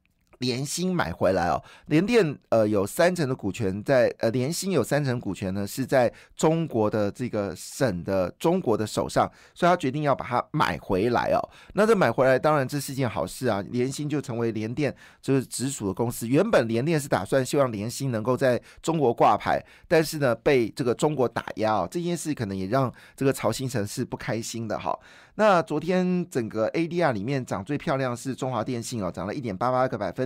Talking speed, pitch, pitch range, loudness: 305 characters per minute, 130 Hz, 110-150 Hz, -25 LUFS